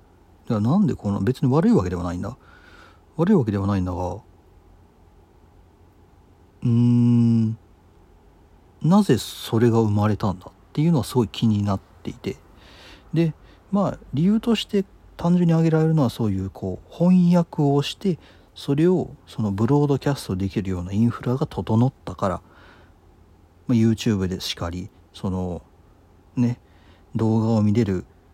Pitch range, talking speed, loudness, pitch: 90-130 Hz, 290 characters per minute, -22 LUFS, 105 Hz